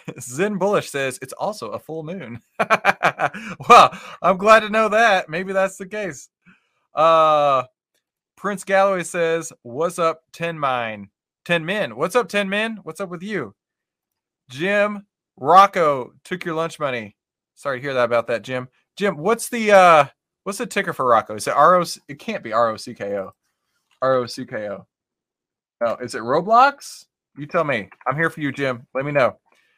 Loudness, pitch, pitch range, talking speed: -19 LUFS, 165 Hz, 130-195 Hz, 185 wpm